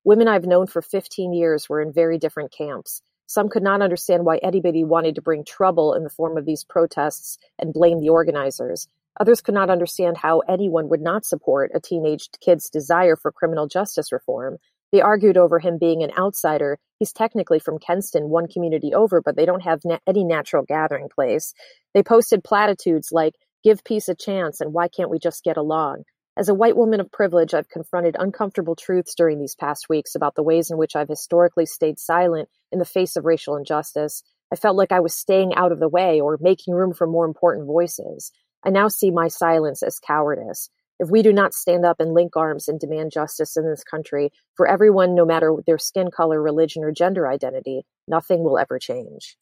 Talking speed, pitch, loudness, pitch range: 205 wpm, 170 Hz, -20 LUFS, 160-190 Hz